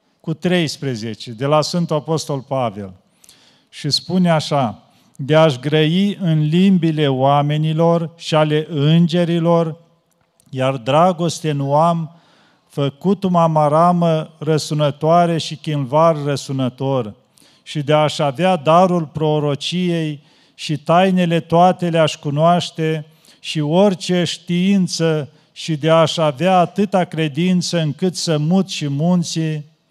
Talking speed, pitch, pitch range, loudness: 110 wpm, 160 Hz, 150-170 Hz, -17 LUFS